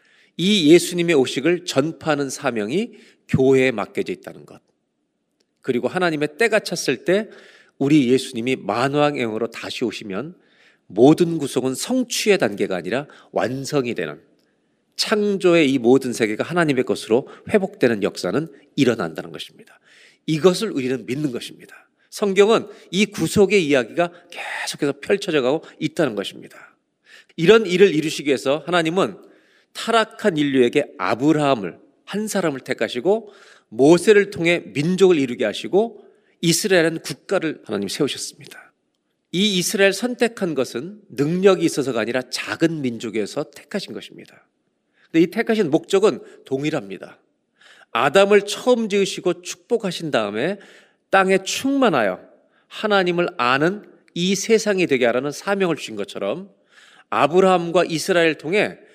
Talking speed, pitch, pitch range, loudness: 320 characters per minute, 165 Hz, 135-200 Hz, -20 LUFS